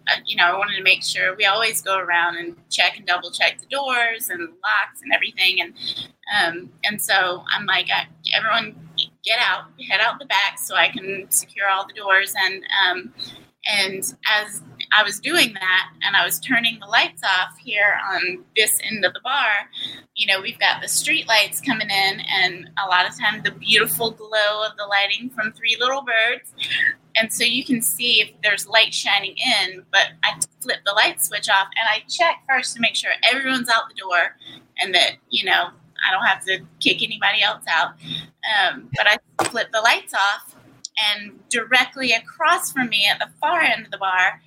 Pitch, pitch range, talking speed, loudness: 210 Hz, 190-235 Hz, 200 wpm, -19 LUFS